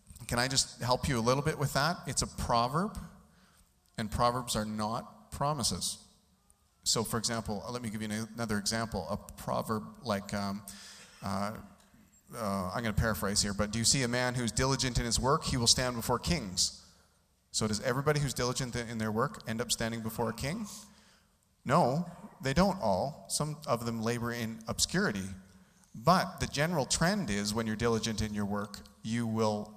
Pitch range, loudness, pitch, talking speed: 105-125 Hz, -32 LUFS, 115 Hz, 185 wpm